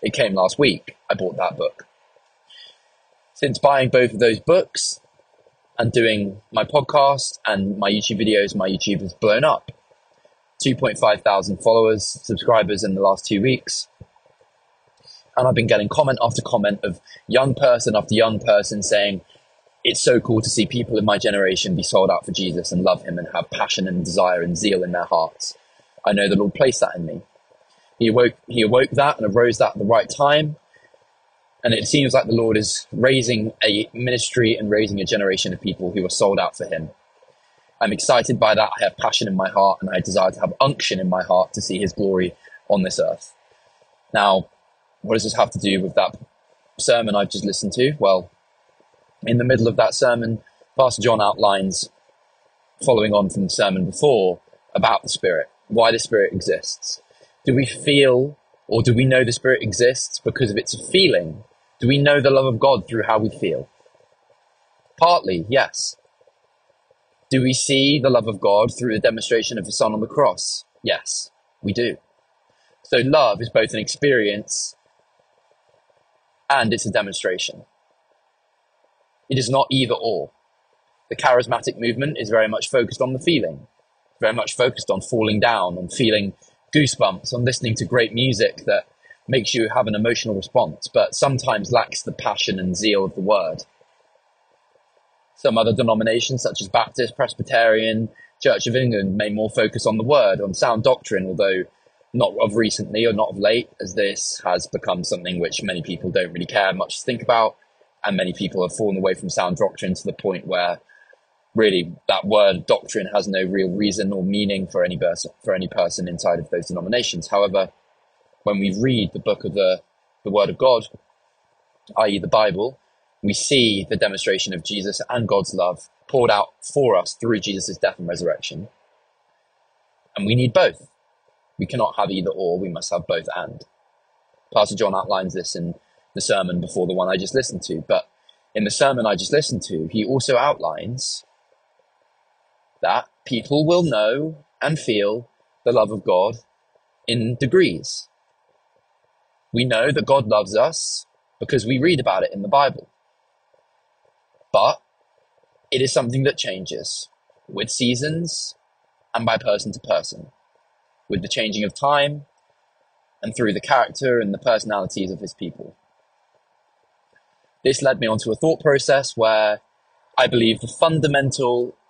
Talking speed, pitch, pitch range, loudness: 175 wpm, 115 Hz, 105-135 Hz, -20 LUFS